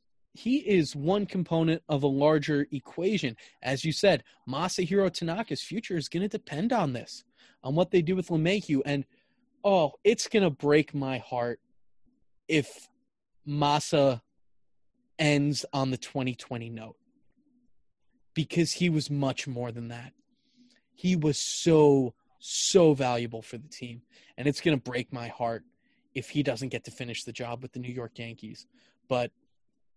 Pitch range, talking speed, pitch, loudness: 125-190 Hz, 155 wpm, 145 Hz, -28 LUFS